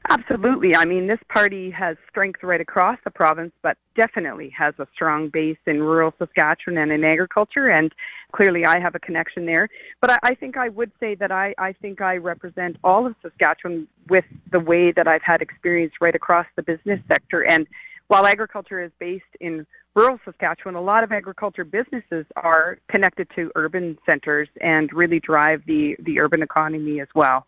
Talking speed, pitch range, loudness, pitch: 185 wpm, 160-200 Hz, -20 LUFS, 175 Hz